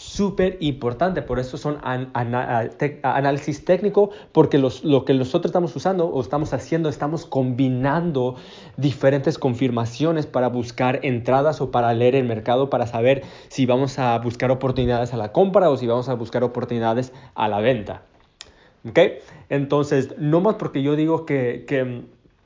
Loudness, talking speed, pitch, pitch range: -21 LUFS, 165 wpm, 135 Hz, 125-150 Hz